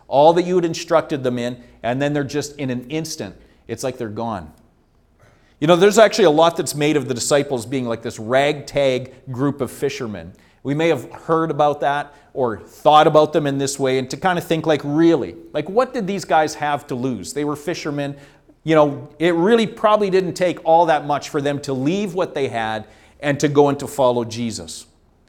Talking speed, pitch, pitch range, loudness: 215 wpm, 145 Hz, 125-160 Hz, -19 LUFS